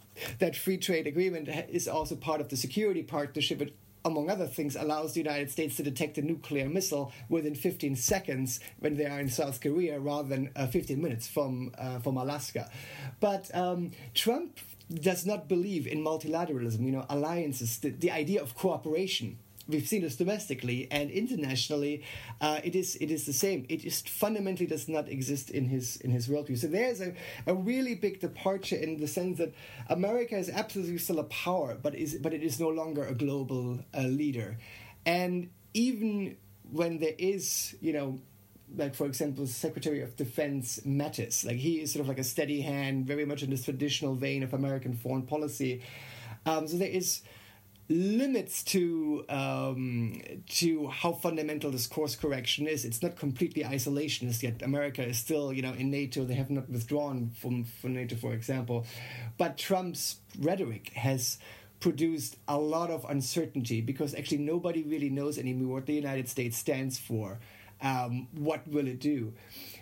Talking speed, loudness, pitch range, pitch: 175 wpm, -33 LUFS, 130-165 Hz, 145 Hz